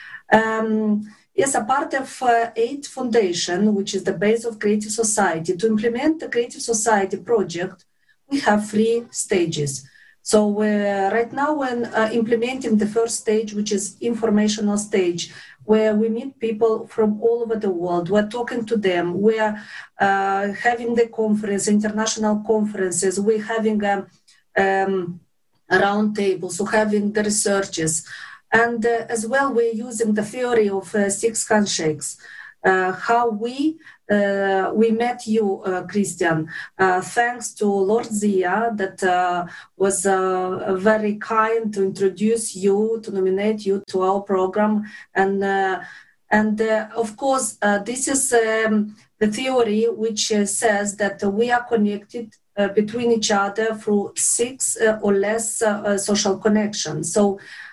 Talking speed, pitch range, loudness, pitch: 150 wpm, 195-230 Hz, -20 LUFS, 215 Hz